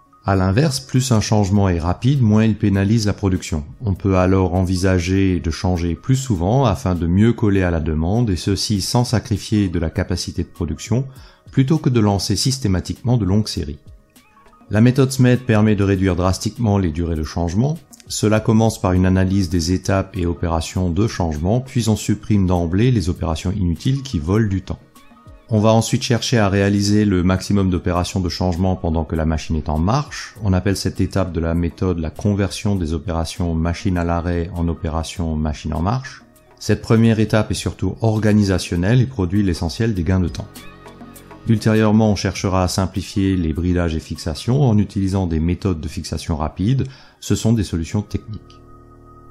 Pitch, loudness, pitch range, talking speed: 95 Hz, -19 LUFS, 90-110 Hz, 180 wpm